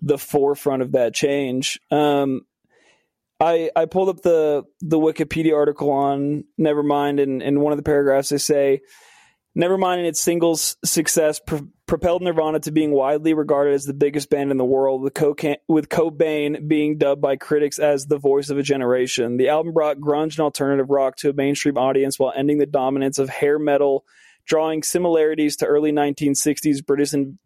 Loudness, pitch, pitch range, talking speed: -20 LUFS, 145 Hz, 140-155 Hz, 180 wpm